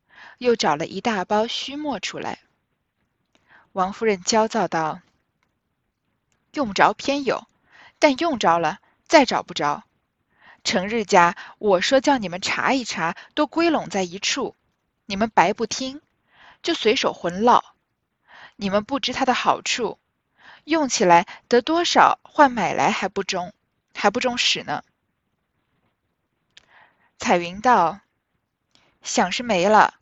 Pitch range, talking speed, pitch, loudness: 190-270 Hz, 180 characters per minute, 225 Hz, -21 LUFS